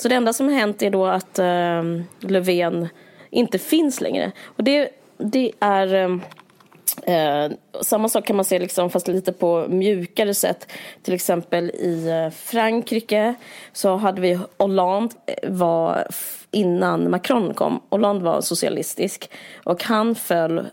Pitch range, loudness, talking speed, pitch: 175-220 Hz, -21 LUFS, 140 wpm, 190 Hz